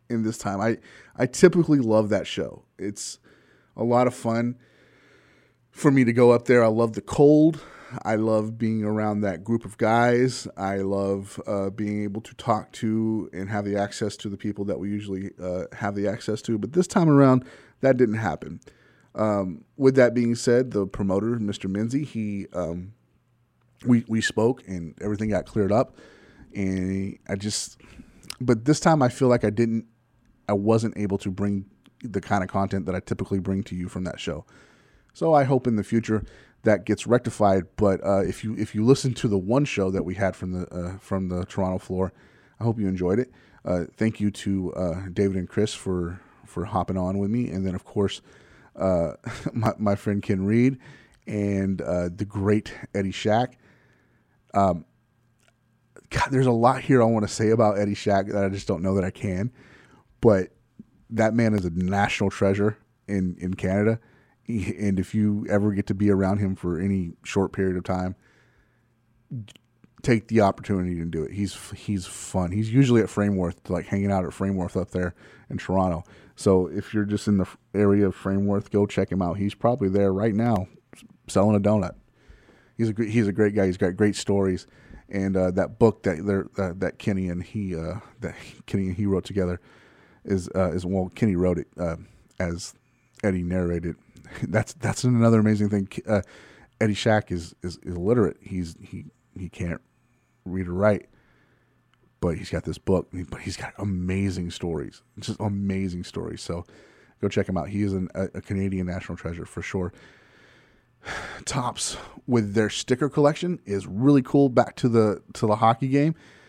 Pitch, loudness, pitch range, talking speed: 100 Hz, -25 LUFS, 95-115 Hz, 190 wpm